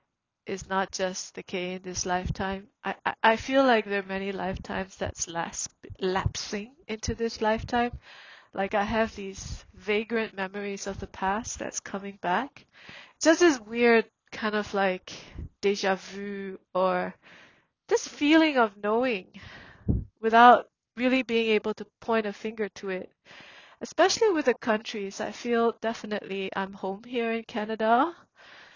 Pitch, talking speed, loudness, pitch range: 210 Hz, 145 wpm, -27 LUFS, 195-230 Hz